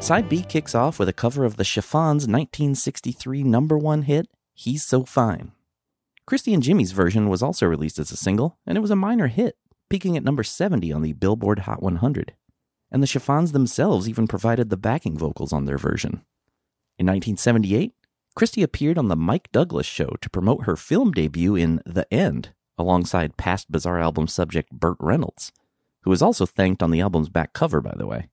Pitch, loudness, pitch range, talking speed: 110 Hz, -22 LUFS, 90-145 Hz, 190 wpm